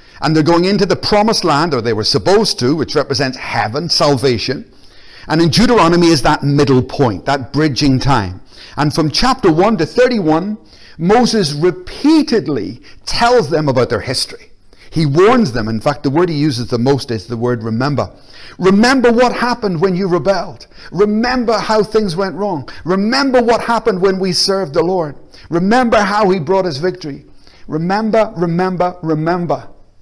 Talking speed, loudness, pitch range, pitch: 165 wpm, -14 LUFS, 140-210 Hz, 175 Hz